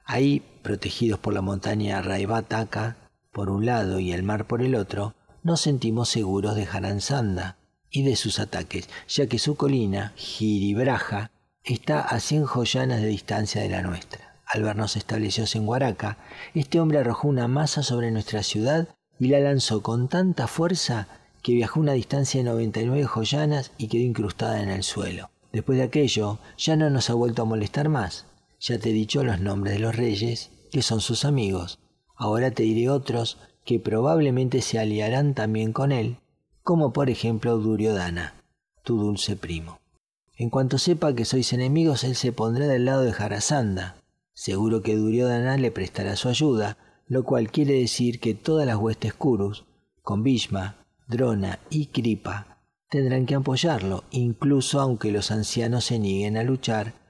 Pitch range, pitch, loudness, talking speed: 105-130 Hz, 115 Hz, -25 LUFS, 165 wpm